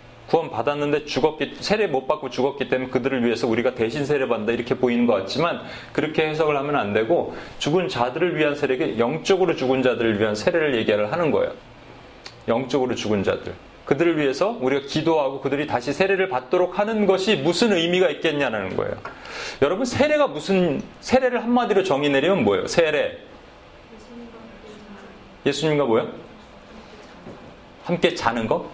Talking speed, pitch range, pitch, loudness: 365 characters per minute, 130-195 Hz, 150 Hz, -22 LUFS